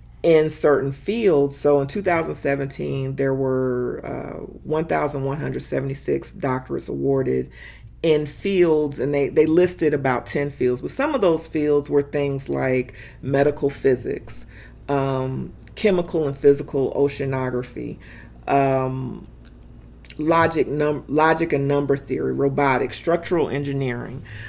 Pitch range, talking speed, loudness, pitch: 130-150 Hz, 115 wpm, -22 LUFS, 140 Hz